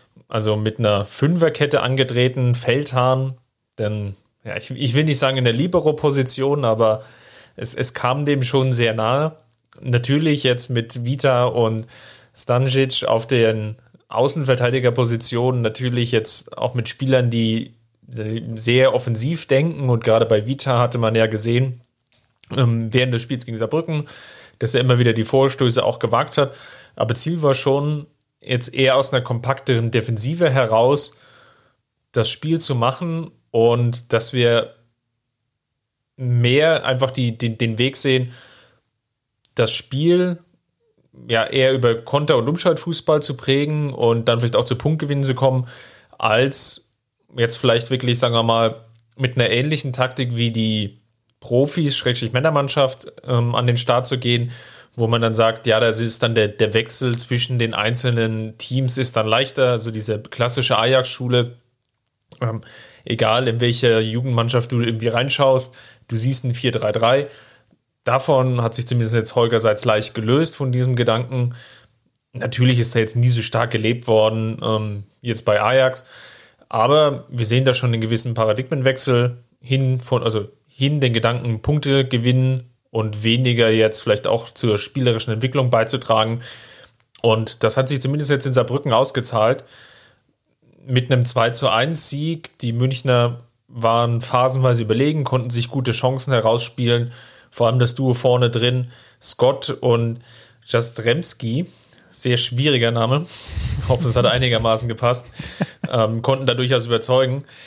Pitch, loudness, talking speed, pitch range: 125 Hz, -19 LUFS, 145 wpm, 115-135 Hz